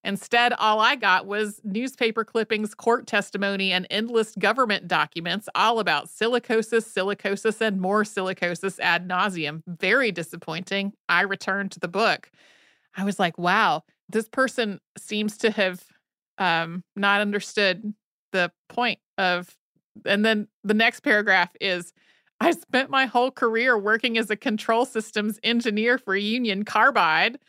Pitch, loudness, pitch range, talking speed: 210 Hz, -23 LUFS, 190-225 Hz, 140 wpm